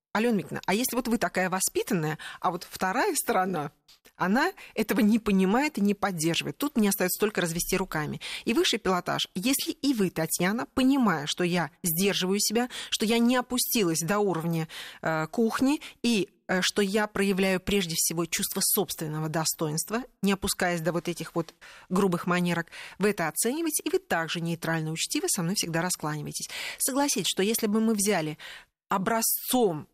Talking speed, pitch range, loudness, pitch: 165 wpm, 170-230 Hz, -27 LUFS, 195 Hz